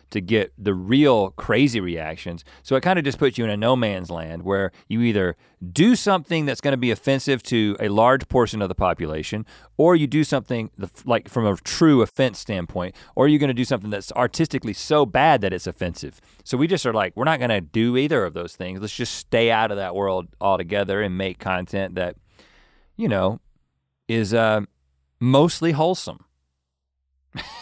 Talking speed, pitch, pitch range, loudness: 195 wpm, 105 Hz, 90-130 Hz, -21 LUFS